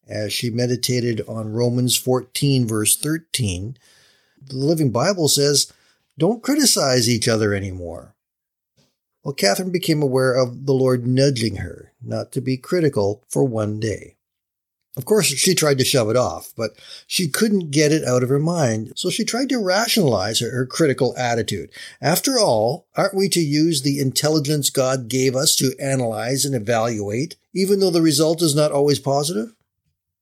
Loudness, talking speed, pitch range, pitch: -19 LUFS, 160 wpm, 120-155 Hz, 135 Hz